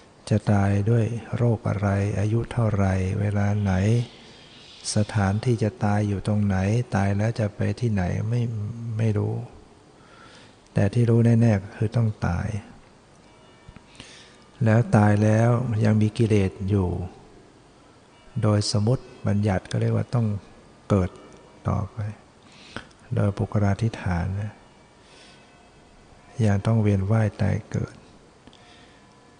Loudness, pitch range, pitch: -24 LUFS, 100-115 Hz, 105 Hz